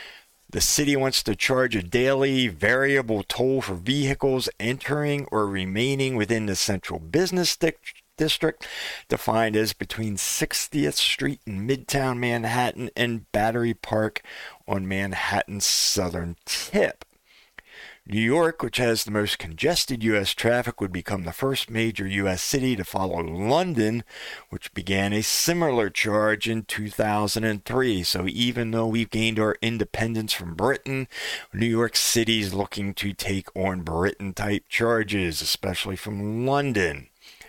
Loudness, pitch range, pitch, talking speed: -24 LUFS, 100-125 Hz, 110 Hz, 130 wpm